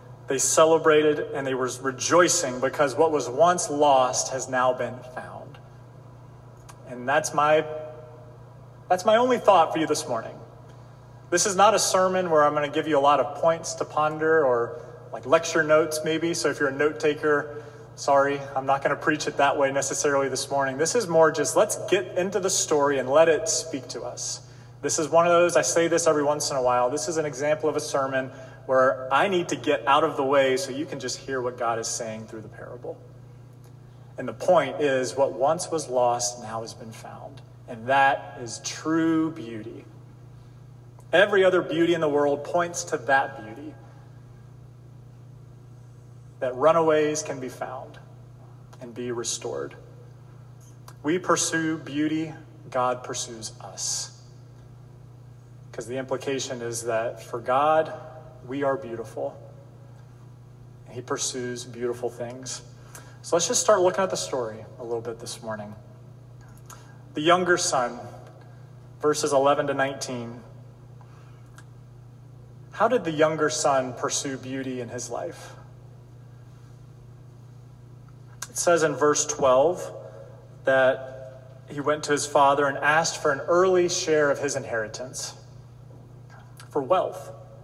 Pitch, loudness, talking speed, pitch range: 130 Hz, -24 LUFS, 155 wpm, 125-150 Hz